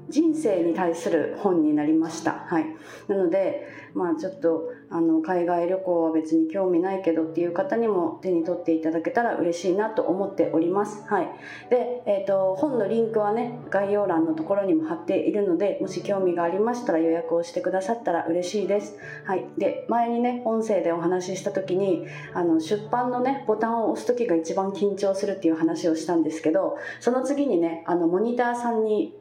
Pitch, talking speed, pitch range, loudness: 195 Hz, 365 characters per minute, 170-240 Hz, -25 LUFS